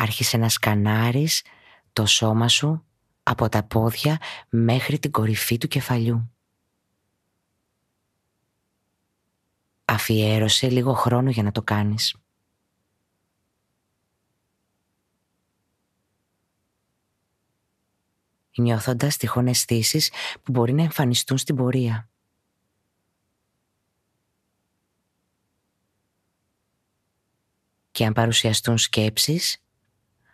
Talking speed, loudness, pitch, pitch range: 65 wpm, -21 LUFS, 110 Hz, 100-120 Hz